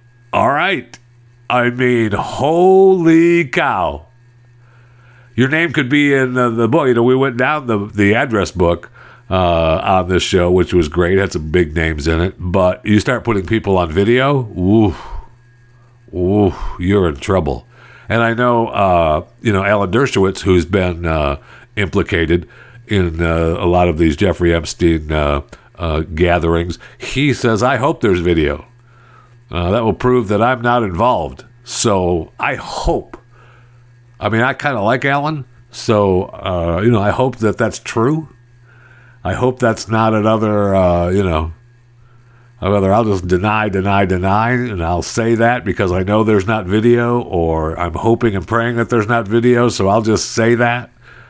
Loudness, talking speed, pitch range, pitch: -15 LUFS, 165 wpm, 90-120 Hz, 110 Hz